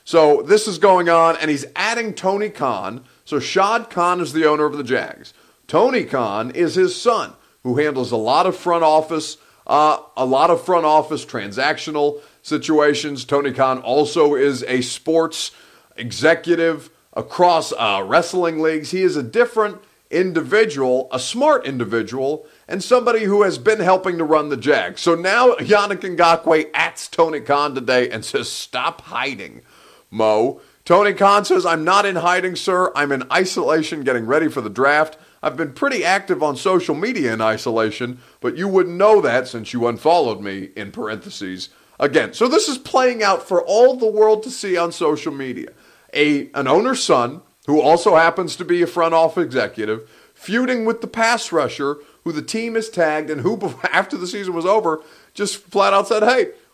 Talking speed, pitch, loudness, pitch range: 175 wpm, 165 Hz, -18 LUFS, 145-195 Hz